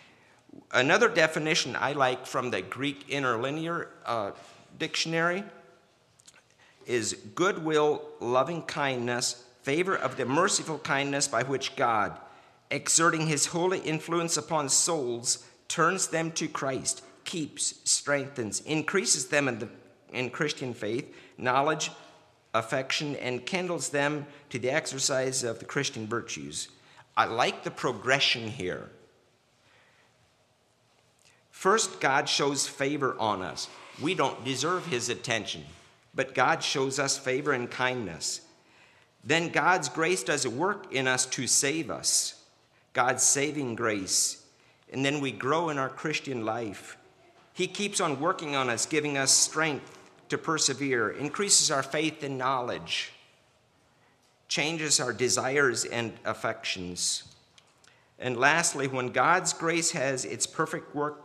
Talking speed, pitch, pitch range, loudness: 125 wpm, 140 Hz, 125-160 Hz, -28 LUFS